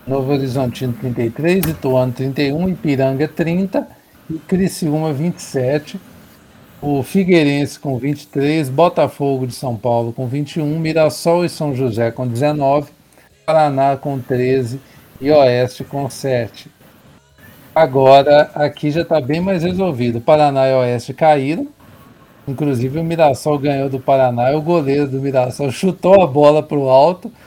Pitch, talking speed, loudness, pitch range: 145 Hz, 135 wpm, -16 LUFS, 130-160 Hz